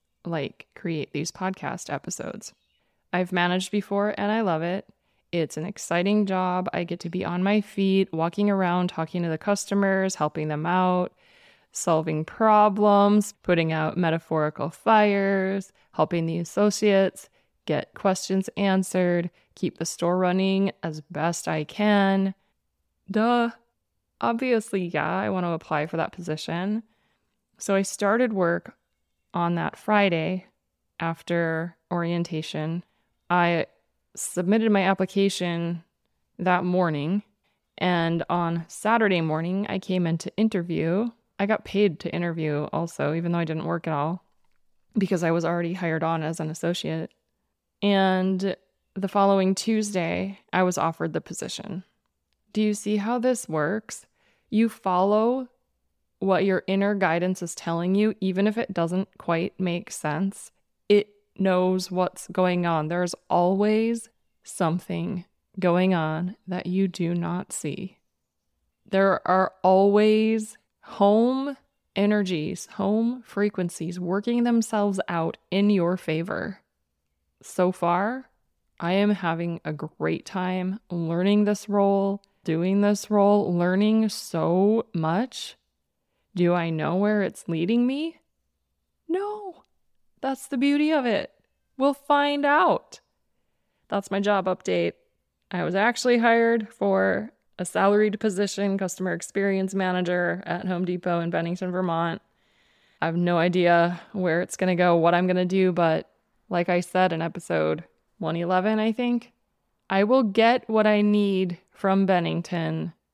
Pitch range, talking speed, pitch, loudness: 170-205 Hz, 135 wpm, 185 Hz, -25 LUFS